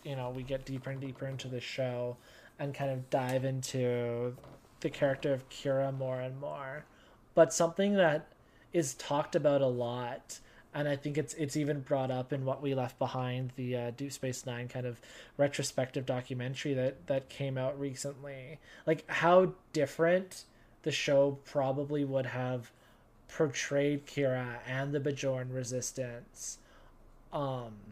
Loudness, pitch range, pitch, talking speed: -34 LUFS, 125-145 Hz, 135 Hz, 155 wpm